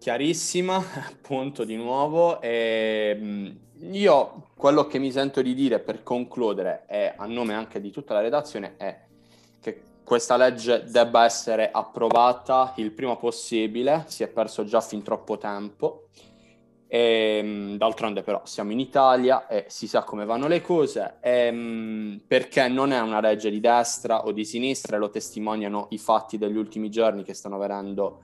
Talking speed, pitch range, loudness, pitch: 155 wpm, 110-130 Hz, -24 LUFS, 115 Hz